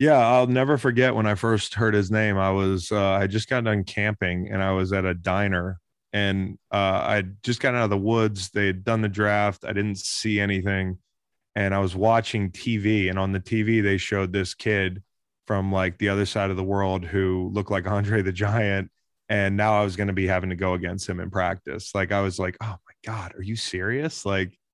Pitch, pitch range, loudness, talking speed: 100 Hz, 95-110 Hz, -24 LUFS, 230 wpm